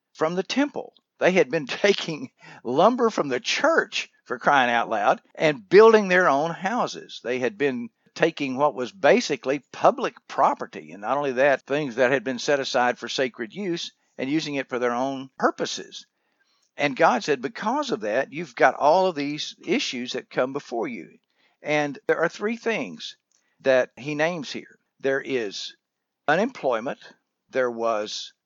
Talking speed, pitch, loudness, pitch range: 165 wpm, 150 Hz, -23 LUFS, 130-205 Hz